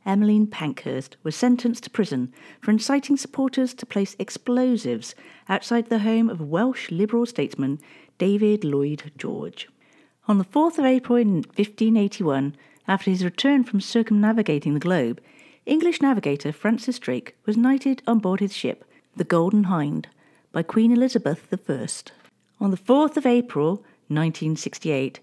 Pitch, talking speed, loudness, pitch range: 210 Hz, 140 wpm, -23 LUFS, 160-245 Hz